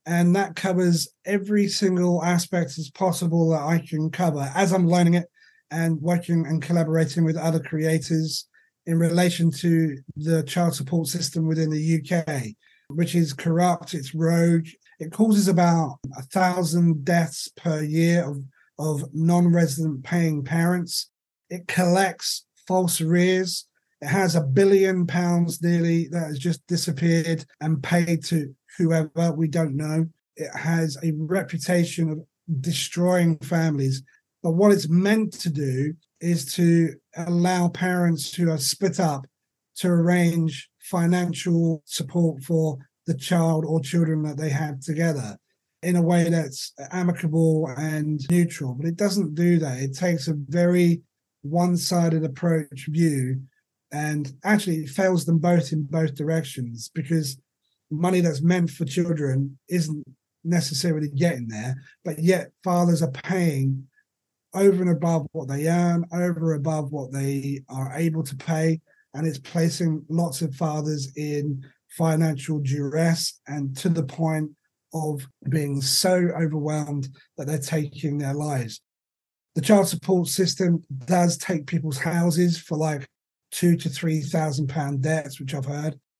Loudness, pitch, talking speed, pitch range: -23 LUFS, 165 Hz, 145 wpm, 150-175 Hz